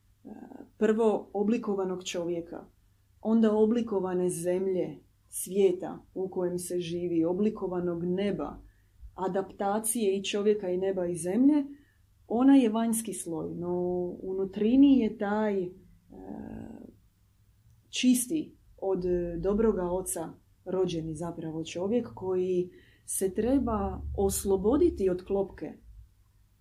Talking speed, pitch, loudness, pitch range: 90 wpm, 185 Hz, -29 LUFS, 175-215 Hz